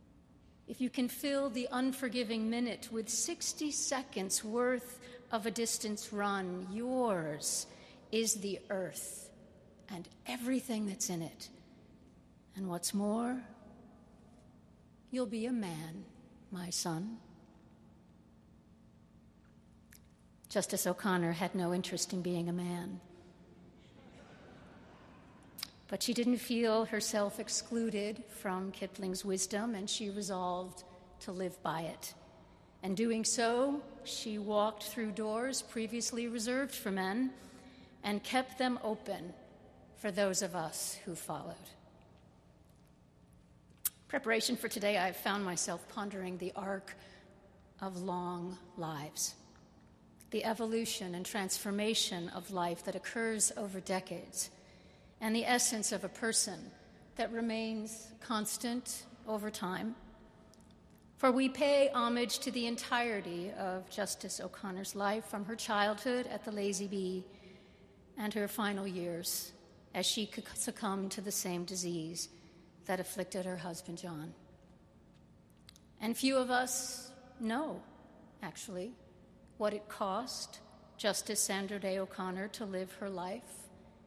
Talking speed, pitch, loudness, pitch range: 115 wpm, 205 Hz, -37 LUFS, 185-230 Hz